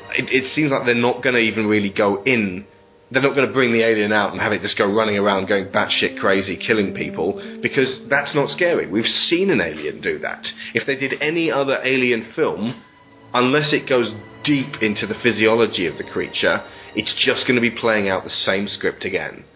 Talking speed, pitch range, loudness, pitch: 215 wpm, 110-135 Hz, -19 LUFS, 120 Hz